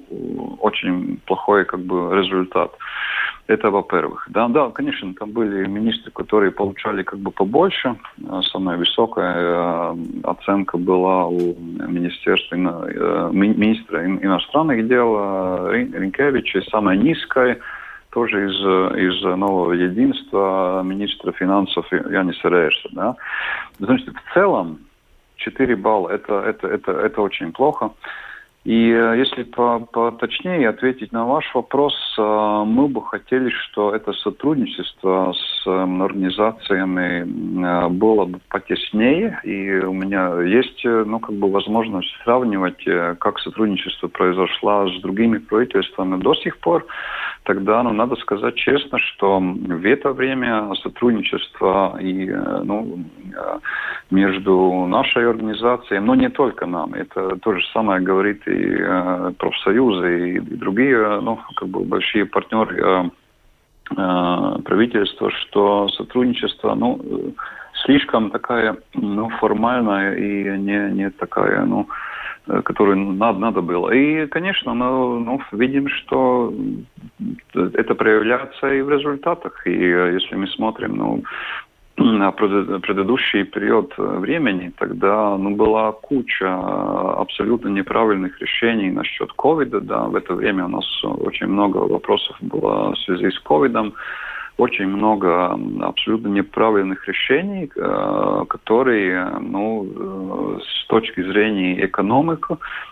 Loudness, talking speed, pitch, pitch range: -19 LUFS, 115 wpm, 100 Hz, 95-115 Hz